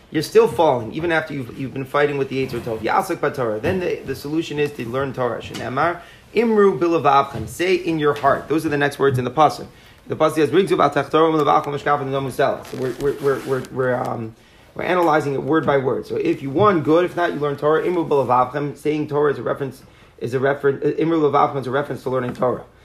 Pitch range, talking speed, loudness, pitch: 135-160 Hz, 235 wpm, -20 LUFS, 145 Hz